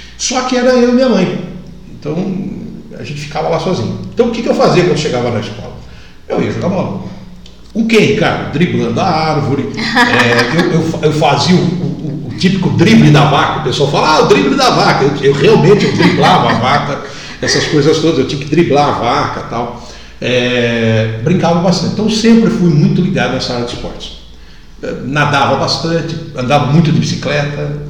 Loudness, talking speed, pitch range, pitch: -11 LUFS, 195 wpm, 140-185 Hz, 155 Hz